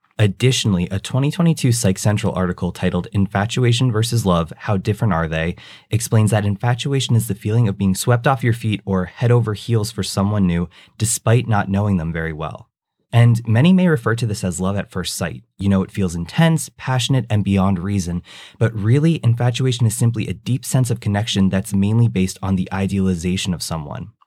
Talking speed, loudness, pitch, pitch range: 190 wpm, -19 LUFS, 105 Hz, 95-120 Hz